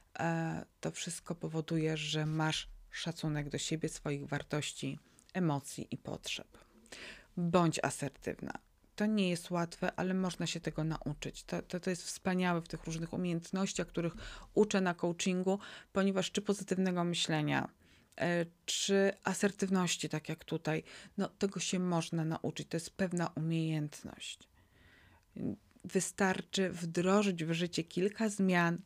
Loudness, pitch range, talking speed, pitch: -36 LUFS, 155-190 Hz, 125 wpm, 170 Hz